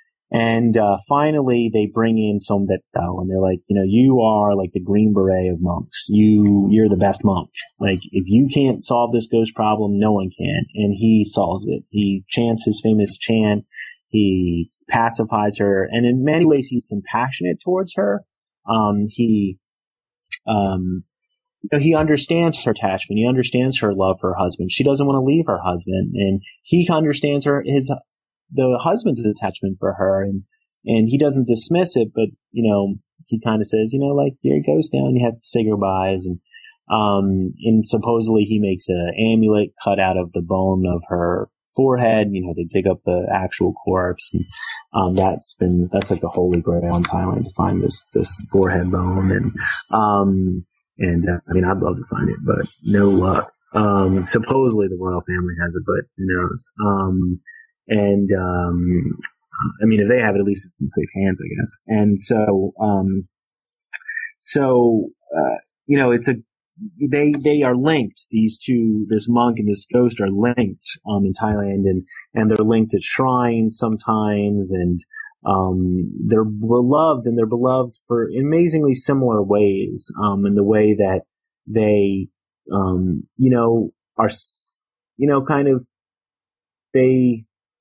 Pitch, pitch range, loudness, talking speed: 105 Hz, 95-120 Hz, -19 LUFS, 175 wpm